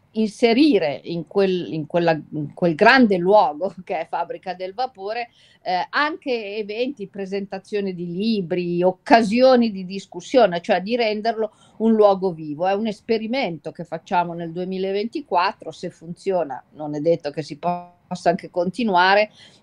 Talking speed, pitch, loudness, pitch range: 140 wpm, 190 Hz, -21 LUFS, 175-215 Hz